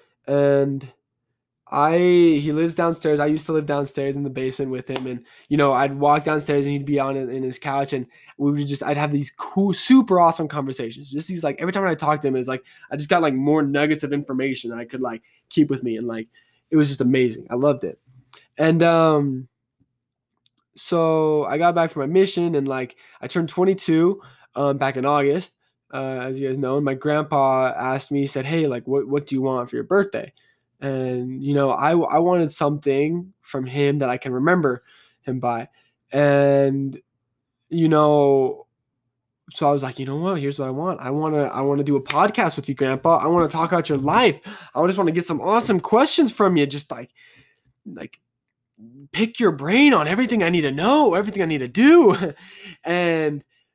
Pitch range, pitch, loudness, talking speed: 130-165 Hz, 145 Hz, -20 LUFS, 210 wpm